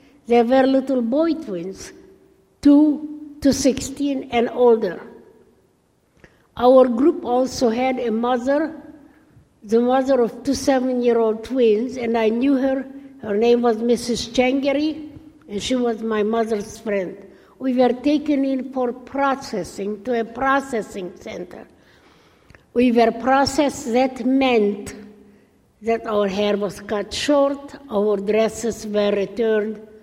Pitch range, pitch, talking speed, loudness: 220-275 Hz, 245 Hz, 125 wpm, -20 LUFS